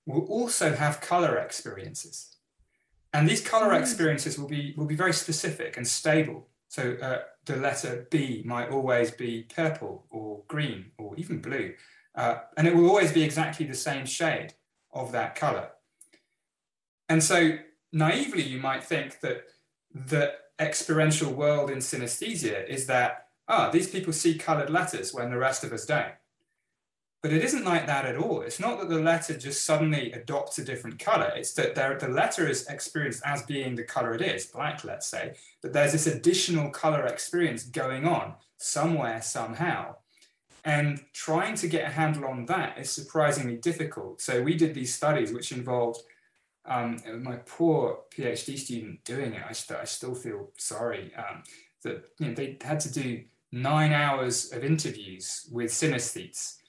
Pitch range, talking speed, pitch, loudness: 130-165 Hz, 170 wpm, 150 Hz, -28 LUFS